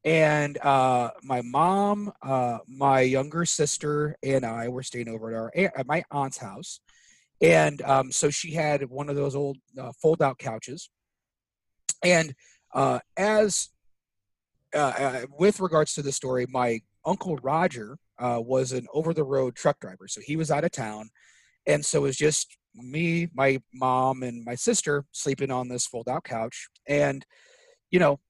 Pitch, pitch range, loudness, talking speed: 135 Hz, 125-155 Hz, -26 LUFS, 165 wpm